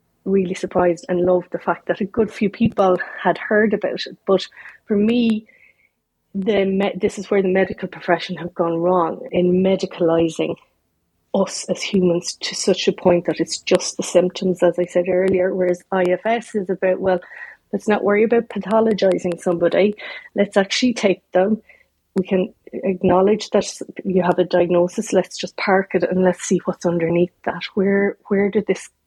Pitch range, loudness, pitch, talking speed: 180-200 Hz, -19 LUFS, 185 Hz, 175 wpm